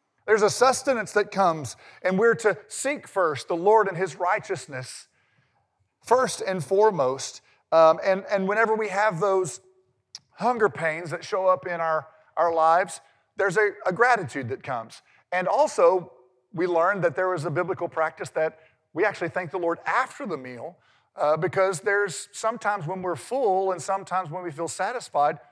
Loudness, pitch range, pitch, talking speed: -24 LUFS, 160-205 Hz, 185 Hz, 170 wpm